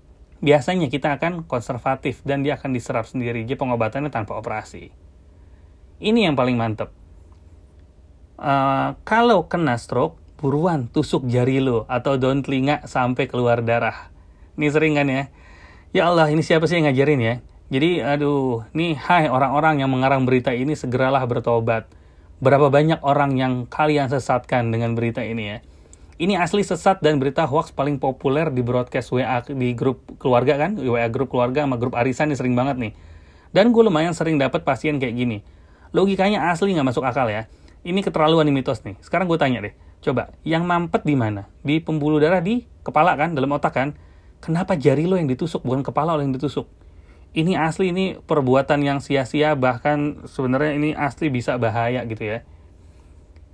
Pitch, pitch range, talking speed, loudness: 135 Hz, 115-150 Hz, 170 wpm, -20 LUFS